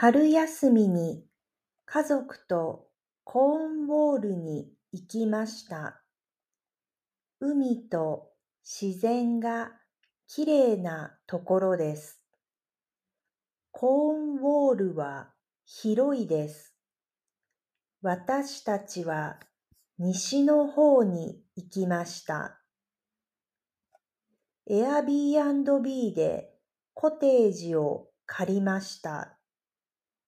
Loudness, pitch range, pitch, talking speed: -27 LUFS, 180-280 Hz, 225 Hz, 150 characters per minute